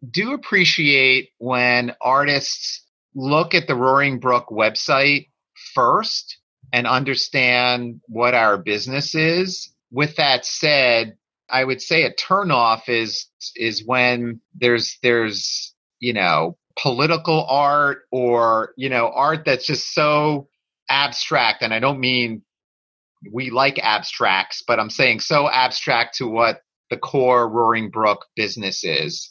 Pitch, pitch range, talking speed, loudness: 130 Hz, 120-145 Hz, 125 wpm, -18 LUFS